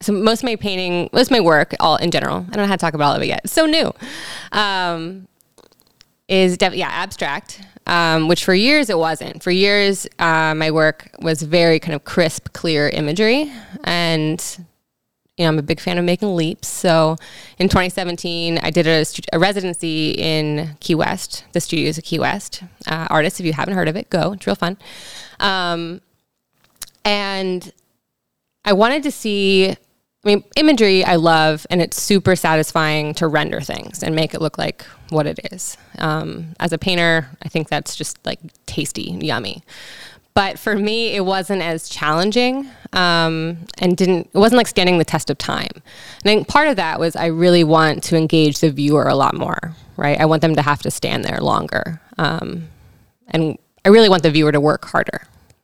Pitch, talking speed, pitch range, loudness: 170 Hz, 195 wpm, 160-195 Hz, -17 LUFS